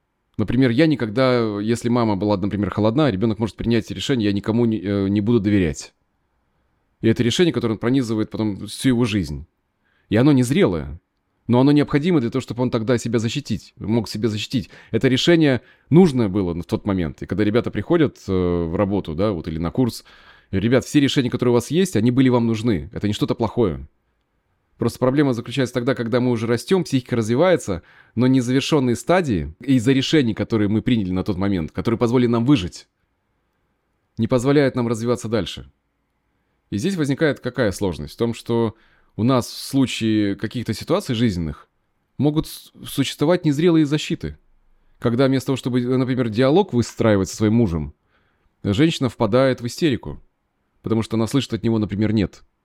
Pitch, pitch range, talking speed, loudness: 115 Hz, 105-130 Hz, 170 wpm, -20 LUFS